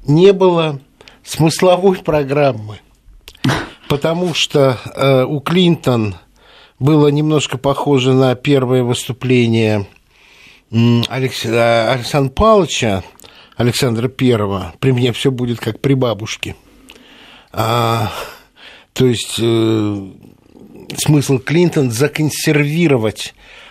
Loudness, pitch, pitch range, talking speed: -15 LUFS, 130 Hz, 115-150 Hz, 85 wpm